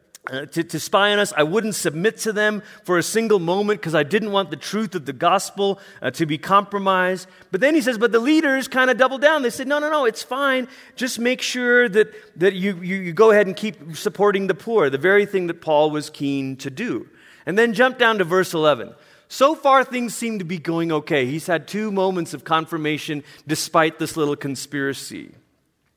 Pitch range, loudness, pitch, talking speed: 160-230 Hz, -20 LUFS, 195 Hz, 220 wpm